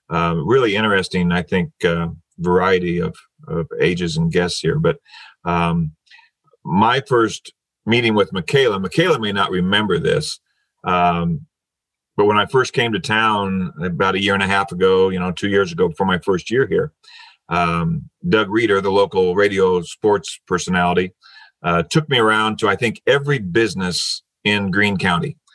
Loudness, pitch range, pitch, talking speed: -18 LUFS, 85-105 Hz, 95 Hz, 165 wpm